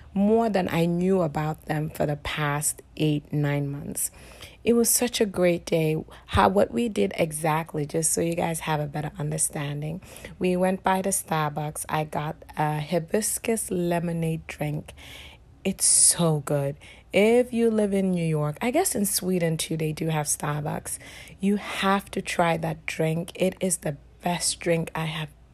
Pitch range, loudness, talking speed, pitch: 155-190 Hz, -25 LUFS, 170 wpm, 165 Hz